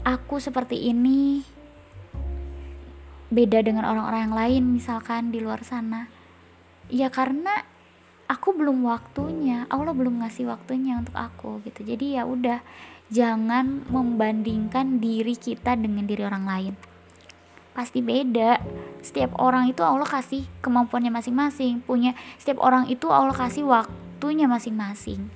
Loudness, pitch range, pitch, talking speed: -24 LUFS, 220-255 Hz, 240 Hz, 125 wpm